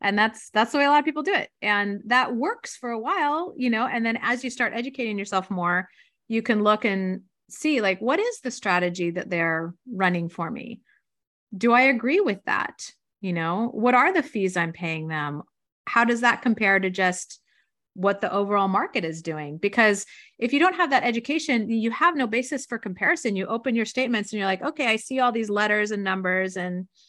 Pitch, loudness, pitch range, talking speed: 225 Hz, -24 LUFS, 190-255 Hz, 215 wpm